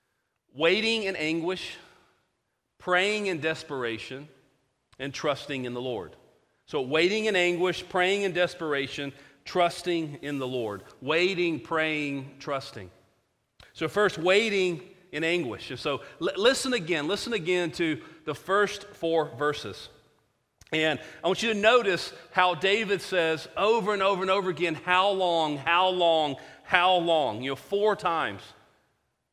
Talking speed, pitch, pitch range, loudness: 135 wpm, 165 Hz, 145-185 Hz, -27 LUFS